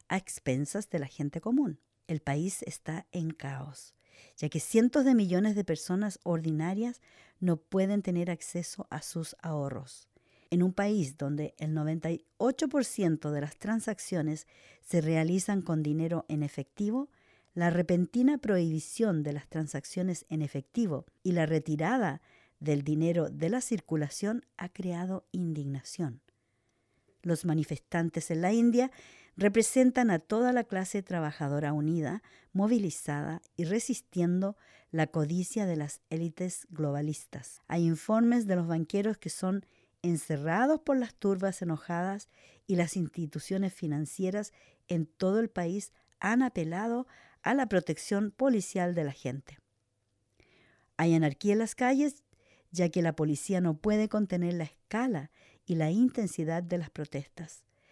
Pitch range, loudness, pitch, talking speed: 155-205 Hz, -31 LUFS, 170 Hz, 135 wpm